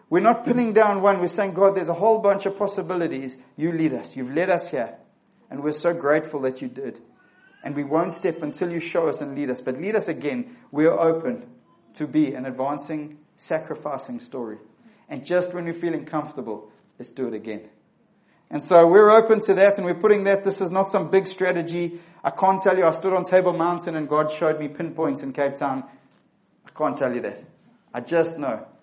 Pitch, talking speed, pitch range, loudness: 170 Hz, 210 wpm, 150-195 Hz, -22 LUFS